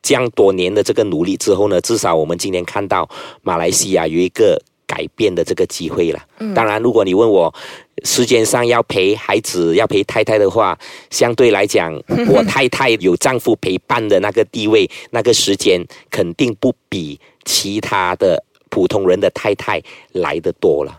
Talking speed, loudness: 270 characters per minute, -15 LUFS